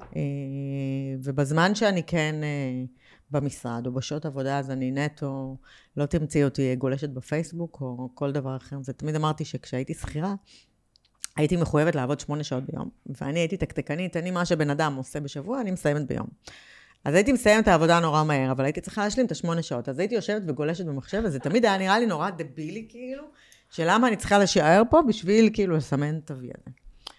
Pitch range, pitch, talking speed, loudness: 140-185 Hz, 150 Hz, 180 wpm, -26 LUFS